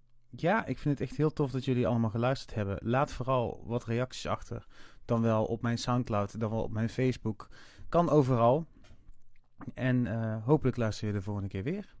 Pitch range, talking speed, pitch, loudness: 110-130 Hz, 190 wpm, 120 Hz, -31 LUFS